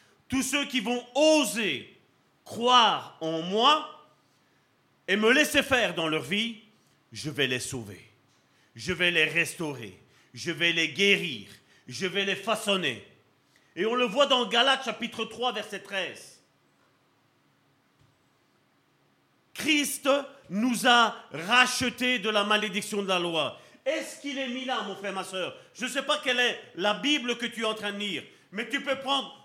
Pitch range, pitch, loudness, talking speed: 190-255 Hz, 225 Hz, -26 LUFS, 160 wpm